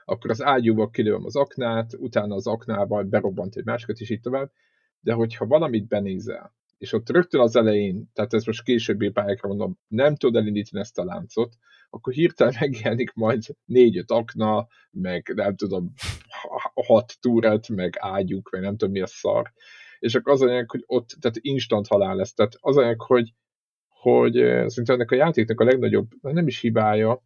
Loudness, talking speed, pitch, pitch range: -23 LUFS, 170 wpm, 115 Hz, 100-125 Hz